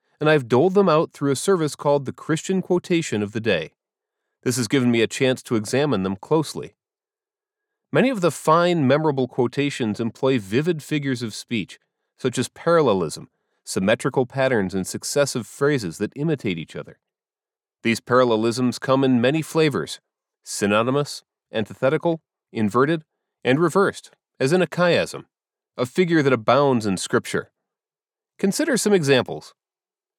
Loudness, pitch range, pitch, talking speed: -21 LUFS, 125-170 Hz, 140 Hz, 145 wpm